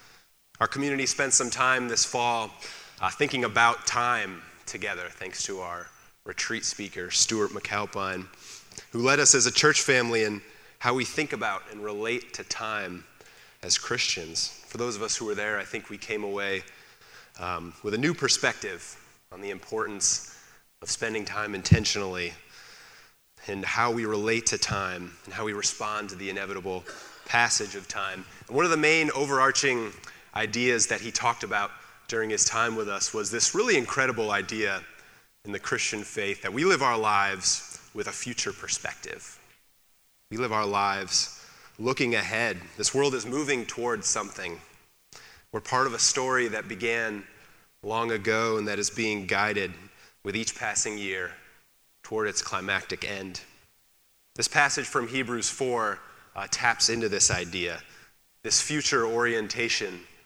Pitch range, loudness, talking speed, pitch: 100-120 Hz, -26 LUFS, 155 wpm, 110 Hz